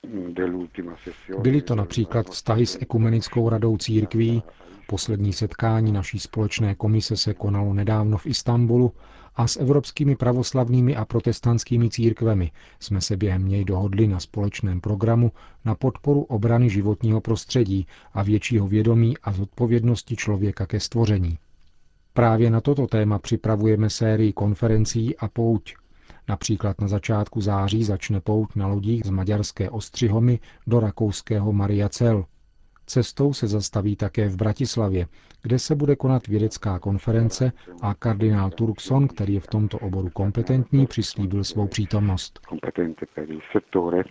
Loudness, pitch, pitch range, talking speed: -23 LUFS, 110 Hz, 100-115 Hz, 125 wpm